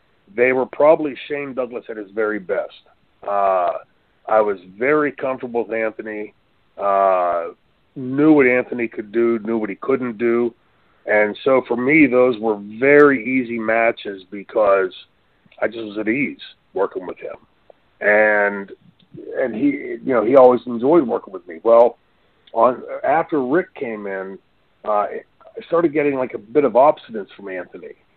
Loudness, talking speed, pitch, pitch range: -18 LUFS, 155 wpm, 120 Hz, 105-145 Hz